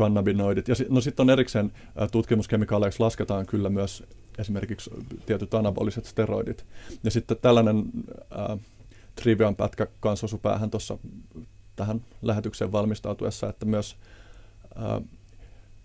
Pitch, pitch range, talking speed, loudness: 105 Hz, 100-115 Hz, 105 wpm, -26 LUFS